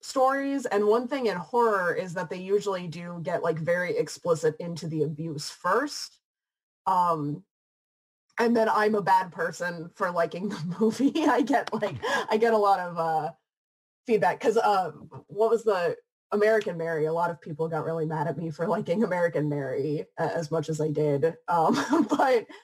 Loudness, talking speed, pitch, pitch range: -27 LUFS, 180 wpm, 185 Hz, 165-230 Hz